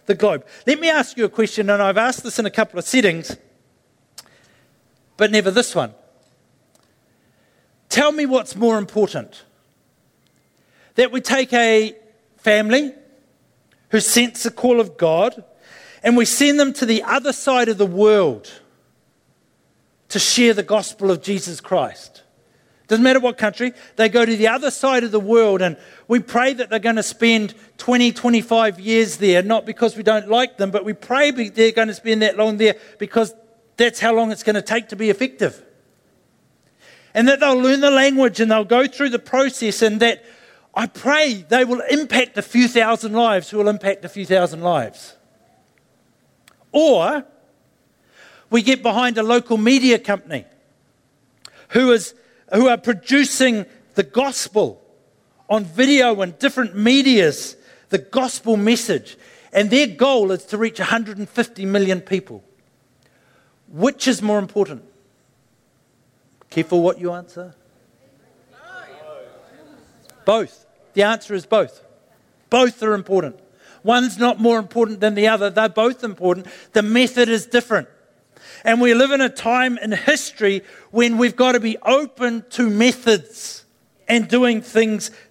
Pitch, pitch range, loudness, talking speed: 225 Hz, 200-245 Hz, -17 LUFS, 155 wpm